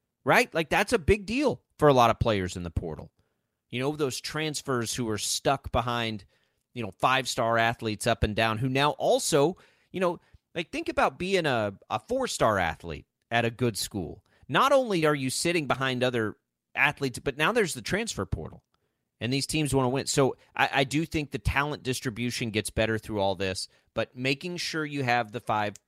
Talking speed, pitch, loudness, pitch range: 205 wpm, 130 Hz, -27 LUFS, 115-155 Hz